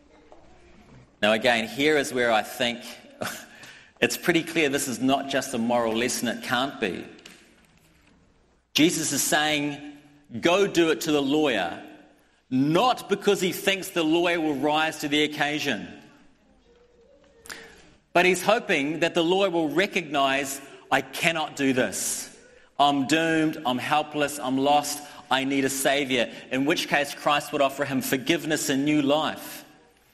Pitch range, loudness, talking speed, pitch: 135-165 Hz, -24 LUFS, 145 wpm, 150 Hz